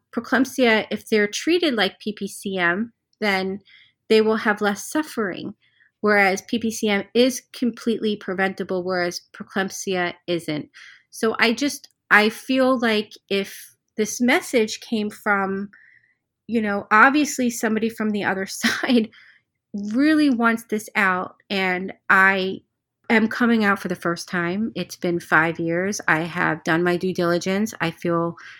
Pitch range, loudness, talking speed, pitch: 185-230 Hz, -21 LUFS, 135 wpm, 205 Hz